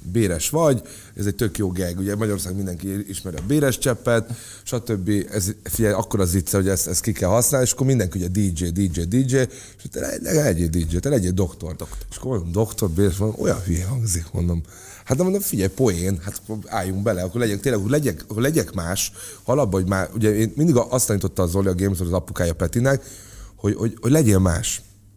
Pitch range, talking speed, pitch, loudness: 95-115 Hz, 210 wpm, 100 Hz, -22 LUFS